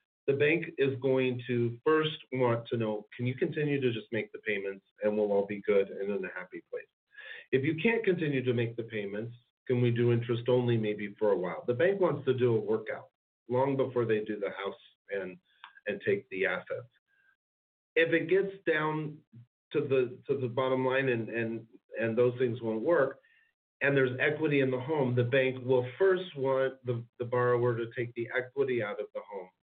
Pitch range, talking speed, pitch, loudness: 120-155 Hz, 205 wpm, 130 Hz, -30 LUFS